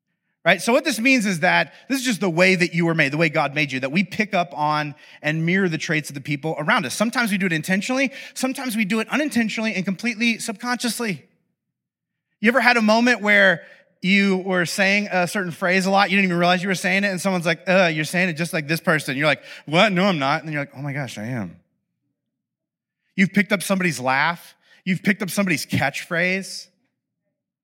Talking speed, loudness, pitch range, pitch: 230 wpm, -20 LUFS, 165-210 Hz, 185 Hz